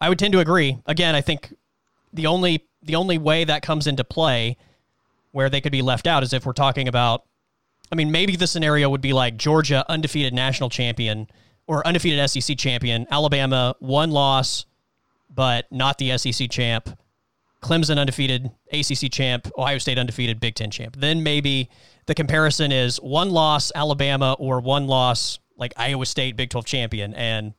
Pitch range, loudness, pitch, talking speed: 125-150 Hz, -21 LUFS, 135 Hz, 175 wpm